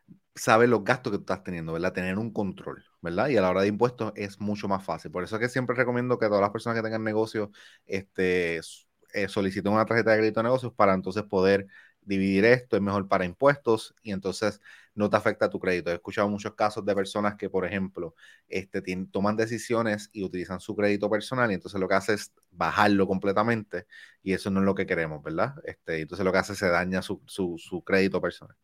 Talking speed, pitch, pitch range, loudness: 225 wpm, 100 Hz, 95-110 Hz, -27 LUFS